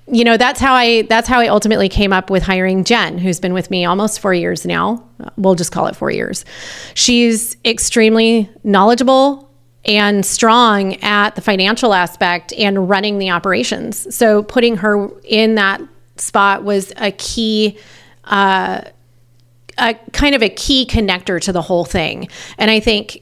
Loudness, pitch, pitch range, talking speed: -13 LUFS, 205 Hz, 185-230 Hz, 165 wpm